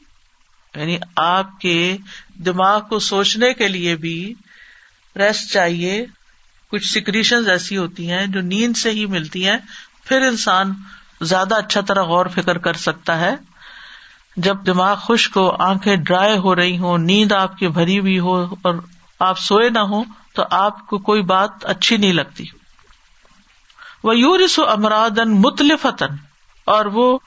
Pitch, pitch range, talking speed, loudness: 195 Hz, 185-215 Hz, 145 wpm, -17 LUFS